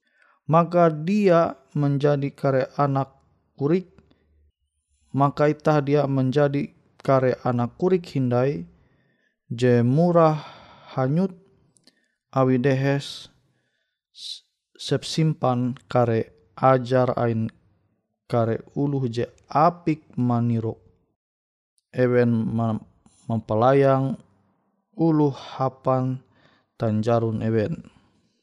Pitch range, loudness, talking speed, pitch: 115-145 Hz, -23 LUFS, 70 wpm, 130 Hz